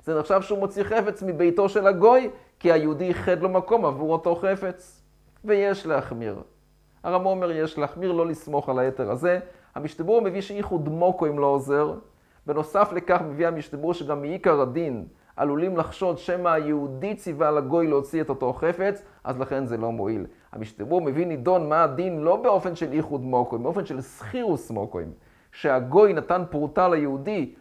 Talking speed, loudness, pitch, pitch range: 160 wpm, -24 LUFS, 165 Hz, 145-185 Hz